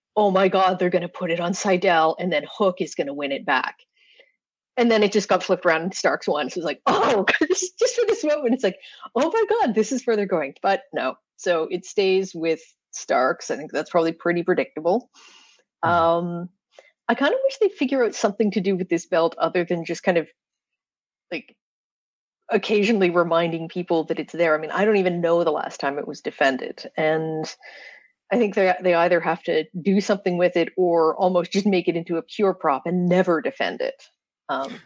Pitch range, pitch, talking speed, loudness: 170-225 Hz, 185 Hz, 210 wpm, -22 LUFS